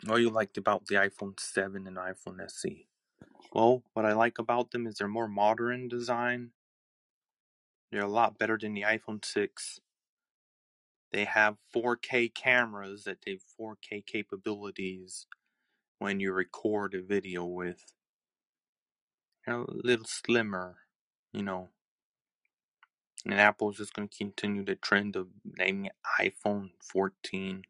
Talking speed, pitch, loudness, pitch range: 135 wpm, 105 Hz, -31 LUFS, 95-115 Hz